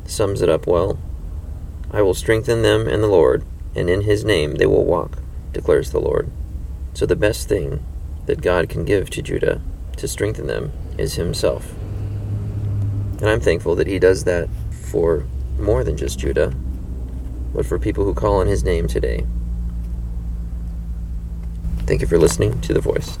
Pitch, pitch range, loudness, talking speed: 75 Hz, 60-100 Hz, -20 LUFS, 165 wpm